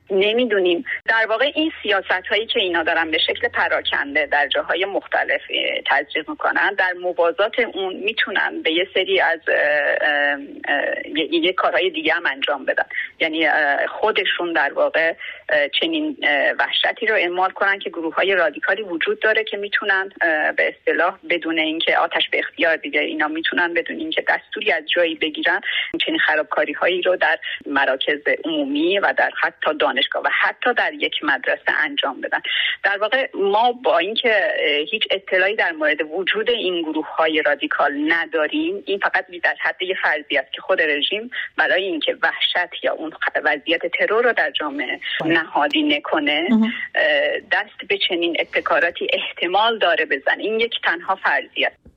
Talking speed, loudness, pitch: 150 wpm, -19 LUFS, 245 Hz